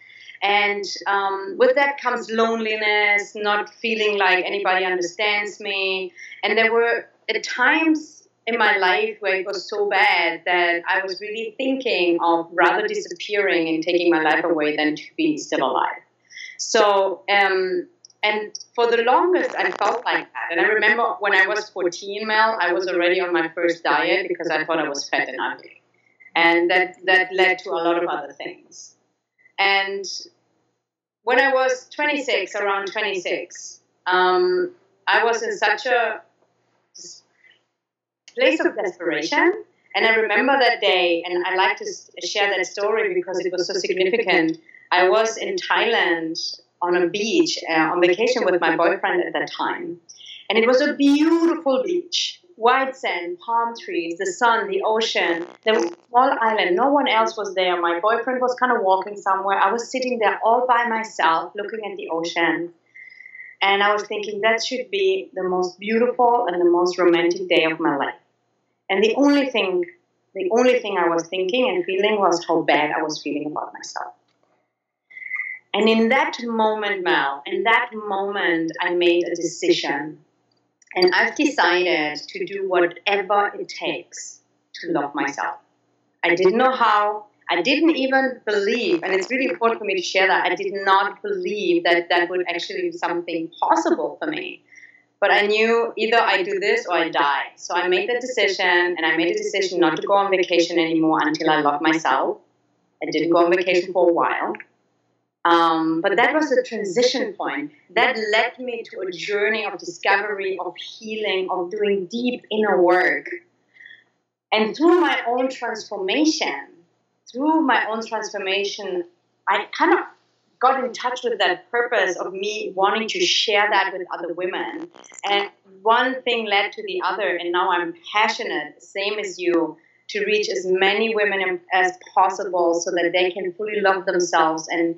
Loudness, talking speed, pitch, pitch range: -20 LUFS, 170 wpm, 200 Hz, 180-245 Hz